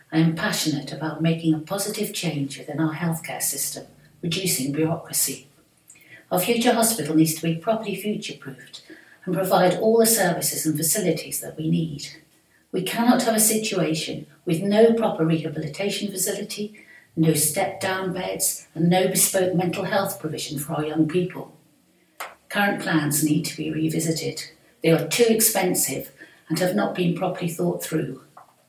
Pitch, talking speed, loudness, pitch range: 170 Hz, 155 wpm, -22 LUFS, 155-200 Hz